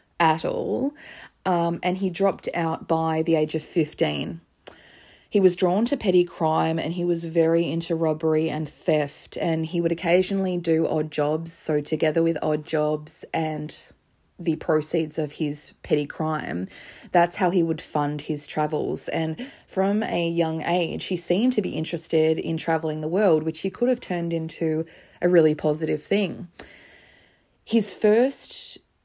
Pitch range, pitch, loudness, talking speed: 155-180 Hz, 165 Hz, -24 LUFS, 160 wpm